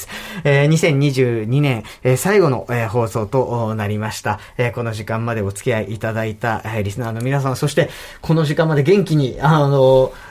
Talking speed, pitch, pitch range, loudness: 295 characters per minute, 125 Hz, 110-145 Hz, -18 LUFS